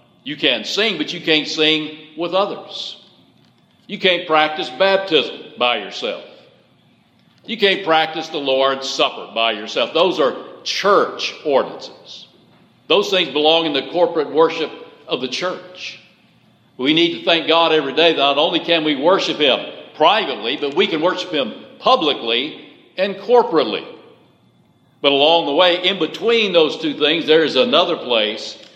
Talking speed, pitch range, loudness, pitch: 150 wpm, 155-195 Hz, -17 LUFS, 165 Hz